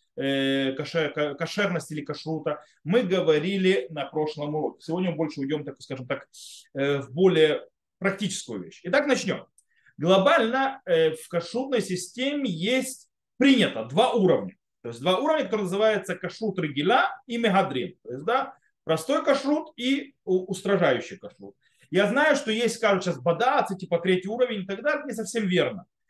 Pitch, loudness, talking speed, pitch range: 190 Hz, -25 LUFS, 145 wpm, 160-240 Hz